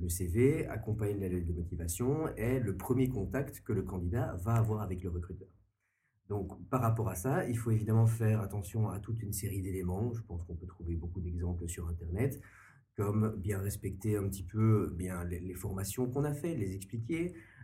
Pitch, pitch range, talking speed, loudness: 105 Hz, 90-115 Hz, 195 wpm, -35 LUFS